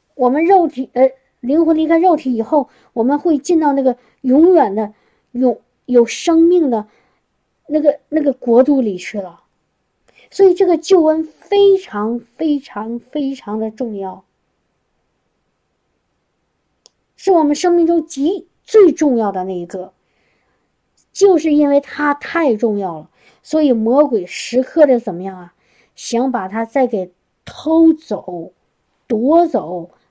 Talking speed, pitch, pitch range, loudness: 190 characters per minute, 265 Hz, 225-315 Hz, -15 LUFS